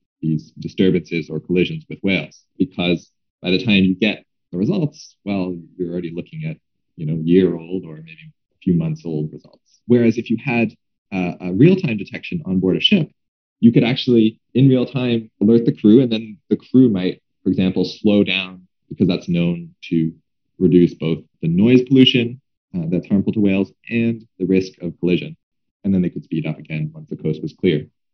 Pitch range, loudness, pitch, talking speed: 85-120 Hz, -18 LUFS, 95 Hz, 195 wpm